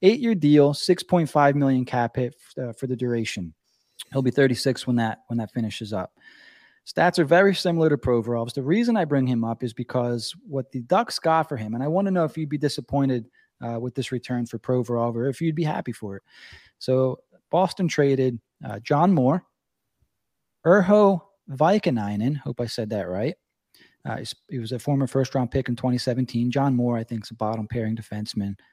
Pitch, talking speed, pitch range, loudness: 130 Hz, 200 wpm, 120-155 Hz, -24 LUFS